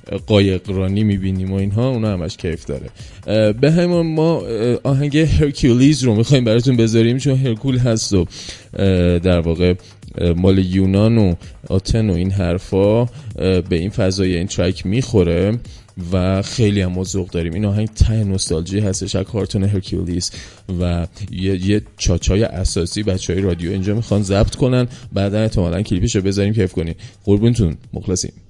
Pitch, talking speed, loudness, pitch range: 100 Hz, 145 wpm, -17 LUFS, 95-110 Hz